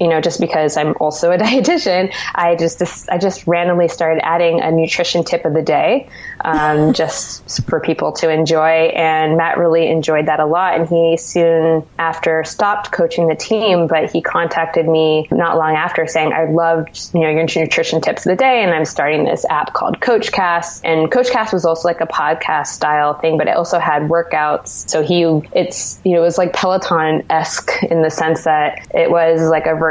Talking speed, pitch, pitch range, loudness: 200 wpm, 165 Hz, 160-170 Hz, -15 LUFS